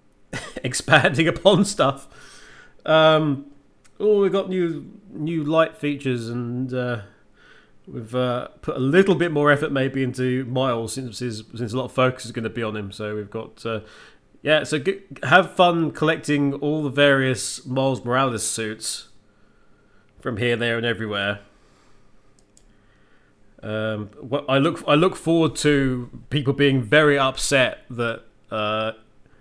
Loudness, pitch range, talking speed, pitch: -21 LUFS, 115-150 Hz, 145 wpm, 130 Hz